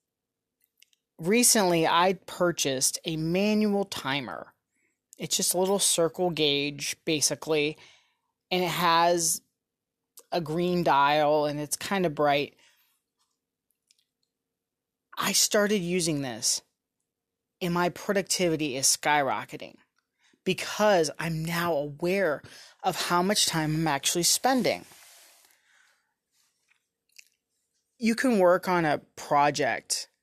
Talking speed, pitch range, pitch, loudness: 100 wpm, 150-200 Hz, 175 Hz, -25 LUFS